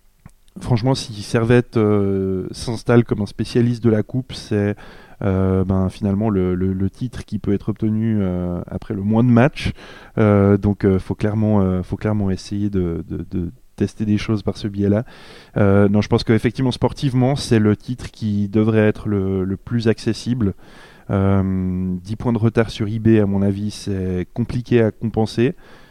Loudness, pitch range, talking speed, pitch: -19 LUFS, 100-115 Hz, 175 wpm, 105 Hz